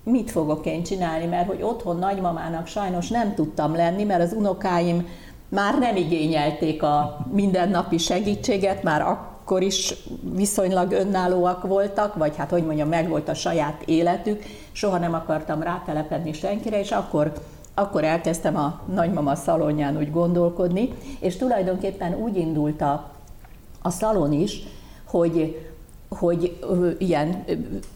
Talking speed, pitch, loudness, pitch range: 135 wpm, 175 Hz, -23 LUFS, 160-195 Hz